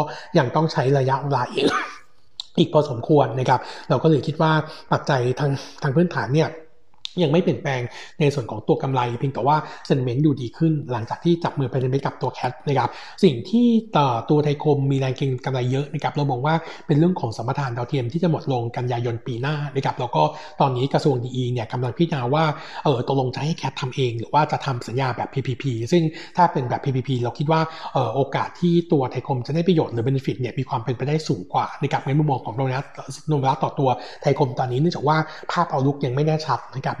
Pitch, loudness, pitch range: 140 Hz, -22 LUFS, 130-155 Hz